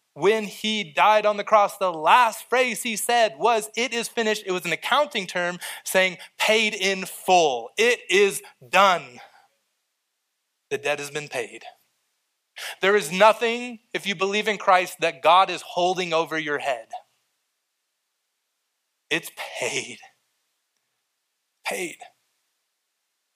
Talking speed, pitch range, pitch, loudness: 130 wpm, 185-235 Hz, 210 Hz, -22 LUFS